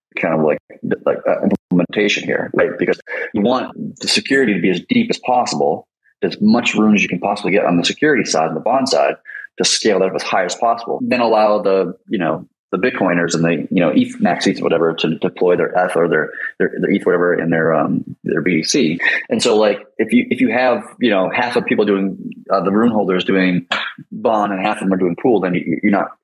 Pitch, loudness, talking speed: 105 Hz, -16 LUFS, 240 wpm